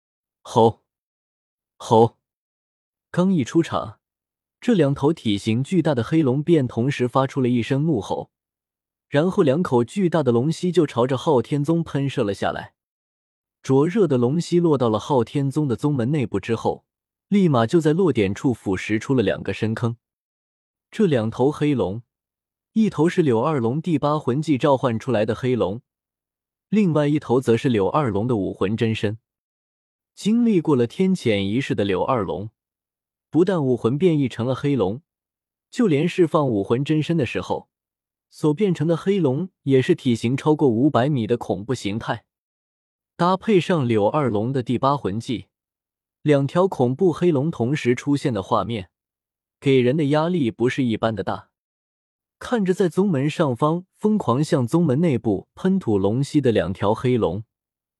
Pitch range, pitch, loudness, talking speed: 115-160 Hz, 135 Hz, -21 LUFS, 235 characters per minute